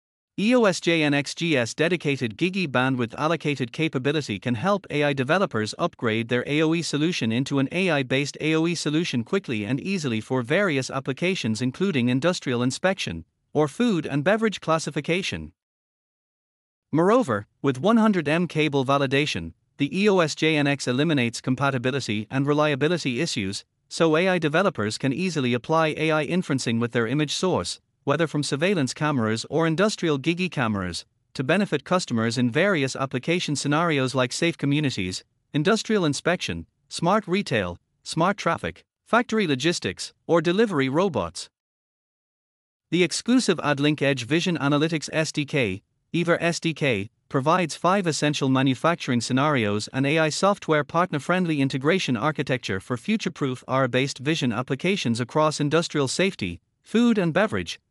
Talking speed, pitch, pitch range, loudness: 120 wpm, 150 Hz, 130-170 Hz, -24 LUFS